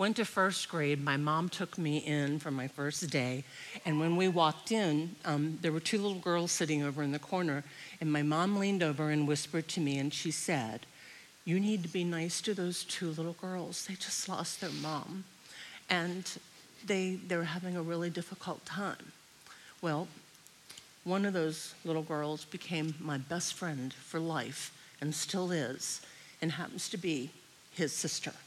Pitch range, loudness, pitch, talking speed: 150-185 Hz, -35 LUFS, 165 Hz, 180 wpm